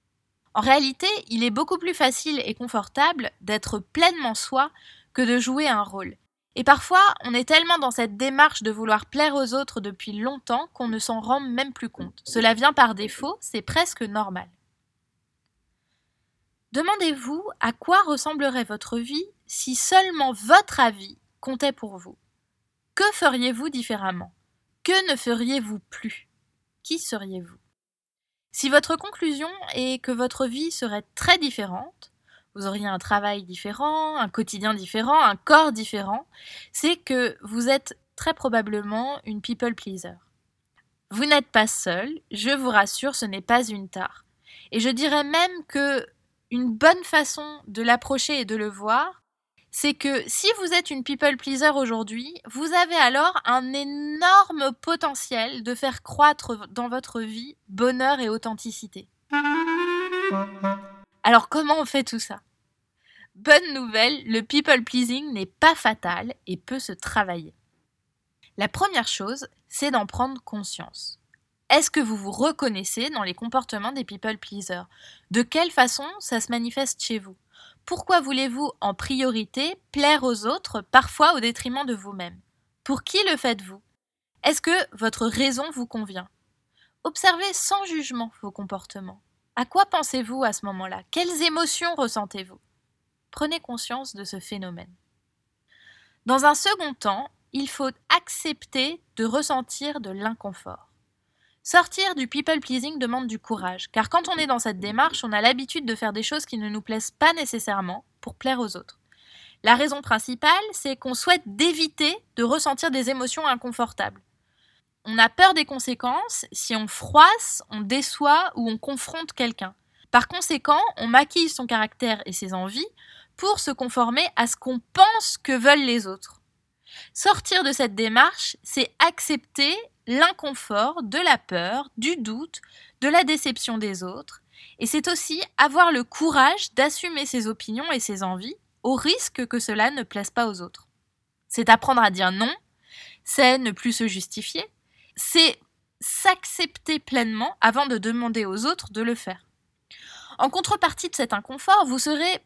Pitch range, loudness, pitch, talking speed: 220-300 Hz, -22 LUFS, 255 Hz, 155 wpm